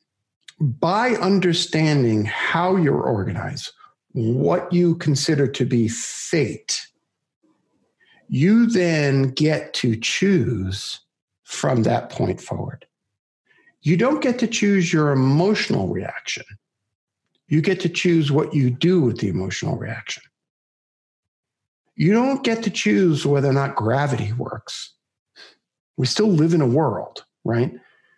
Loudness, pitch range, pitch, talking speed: -20 LUFS, 130-190 Hz, 160 Hz, 120 wpm